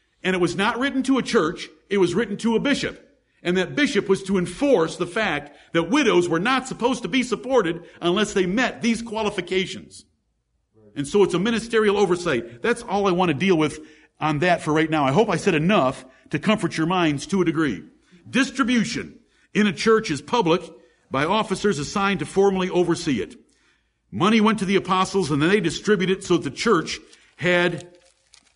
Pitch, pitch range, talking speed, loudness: 185 Hz, 165-215 Hz, 195 wpm, -22 LUFS